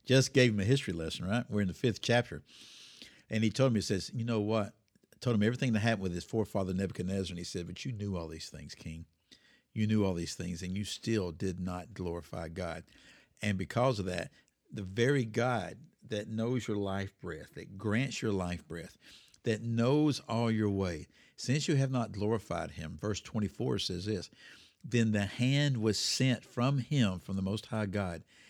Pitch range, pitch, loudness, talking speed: 95-120 Hz, 105 Hz, -33 LUFS, 205 wpm